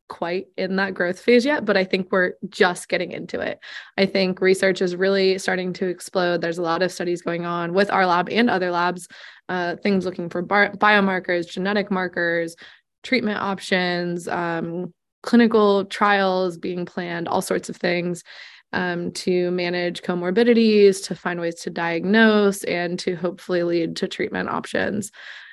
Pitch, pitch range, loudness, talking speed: 185 Hz, 175-195 Hz, -21 LUFS, 165 wpm